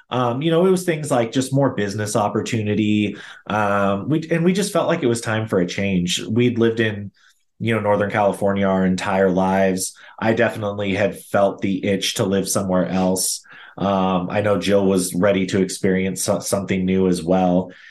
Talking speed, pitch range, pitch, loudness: 190 wpm, 95-115 Hz, 100 Hz, -20 LUFS